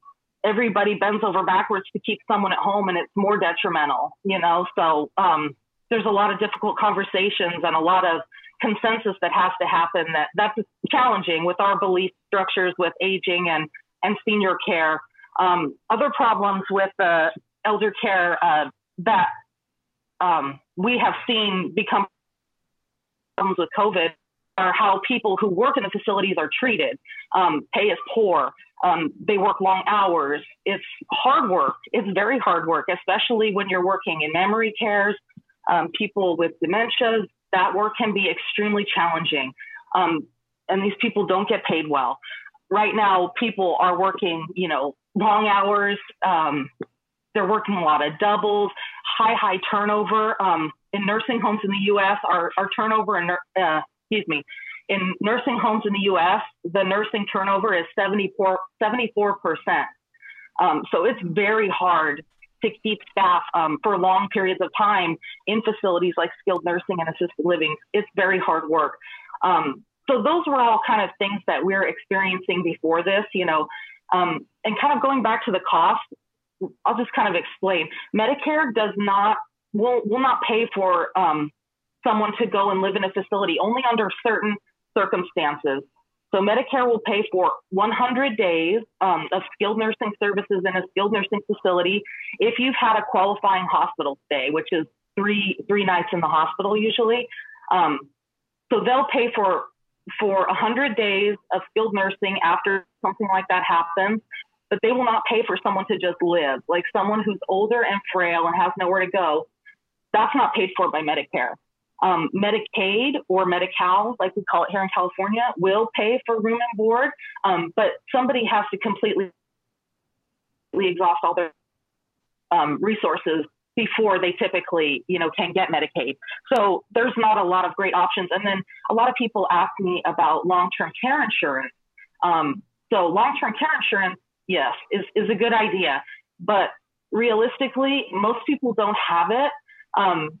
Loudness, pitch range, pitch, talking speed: -22 LUFS, 185-225 Hz, 200 Hz, 165 wpm